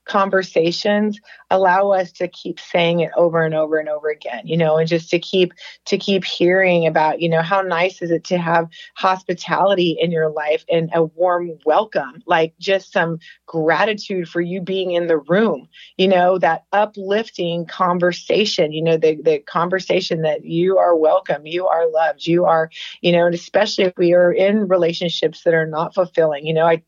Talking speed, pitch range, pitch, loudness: 190 wpm, 165-190 Hz, 175 Hz, -18 LUFS